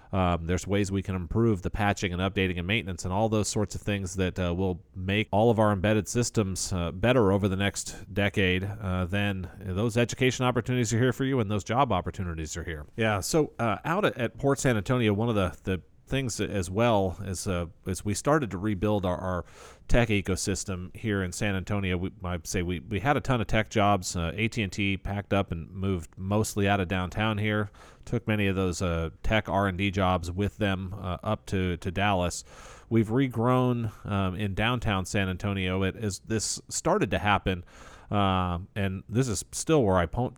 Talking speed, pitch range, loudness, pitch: 205 wpm, 95-110 Hz, -28 LUFS, 100 Hz